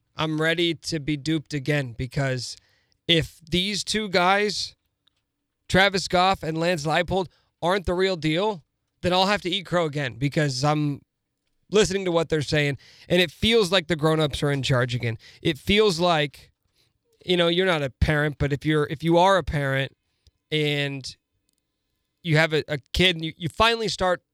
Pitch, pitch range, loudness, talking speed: 160 Hz, 145-180 Hz, -23 LUFS, 180 wpm